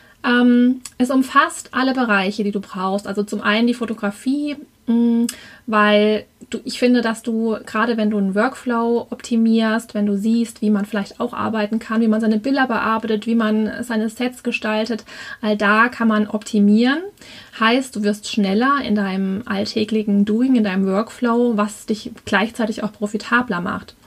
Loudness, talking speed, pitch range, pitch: -19 LUFS, 165 wpm, 210-235 Hz, 225 Hz